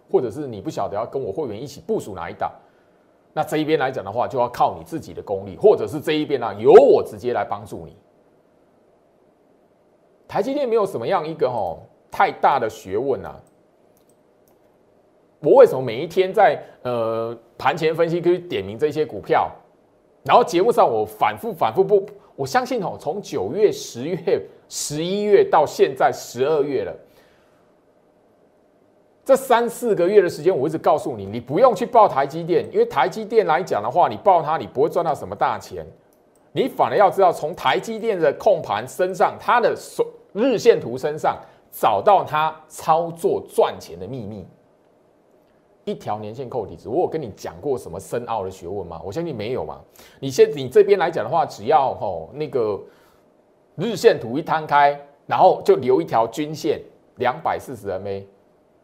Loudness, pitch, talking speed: -20 LUFS, 190 Hz, 260 characters per minute